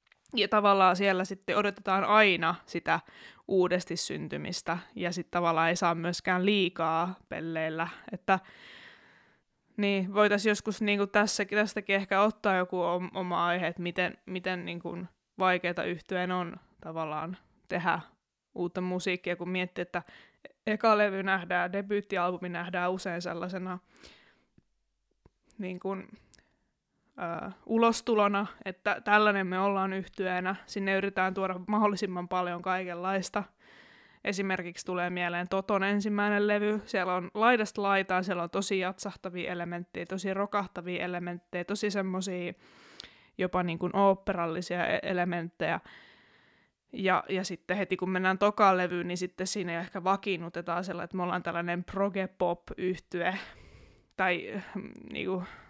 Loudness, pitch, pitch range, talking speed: -30 LUFS, 185 Hz, 175-200 Hz, 125 wpm